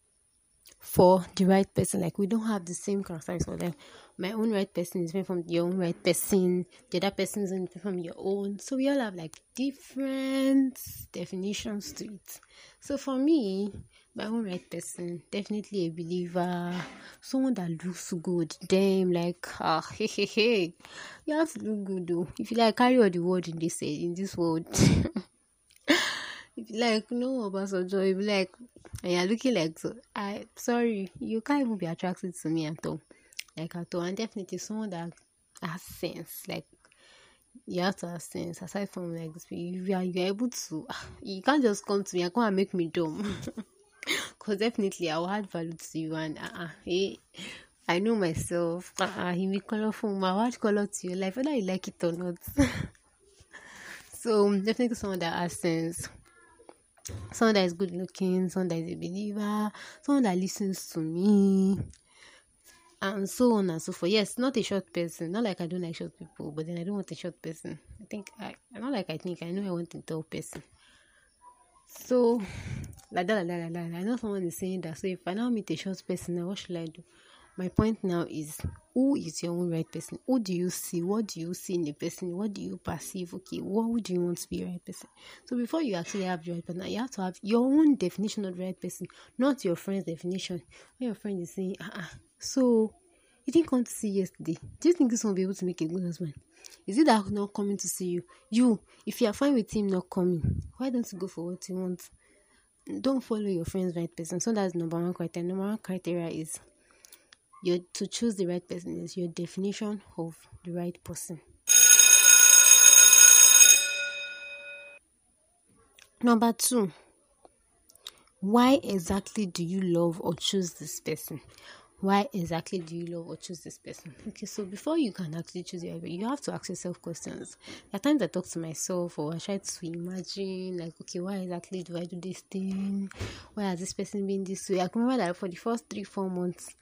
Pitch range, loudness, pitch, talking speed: 175-220 Hz, -27 LUFS, 190 Hz, 205 wpm